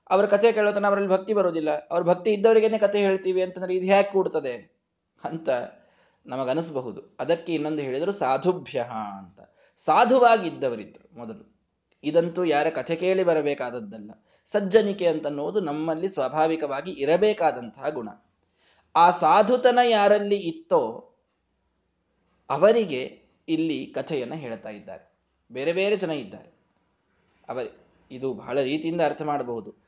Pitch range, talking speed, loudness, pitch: 145-205 Hz, 110 wpm, -23 LUFS, 170 Hz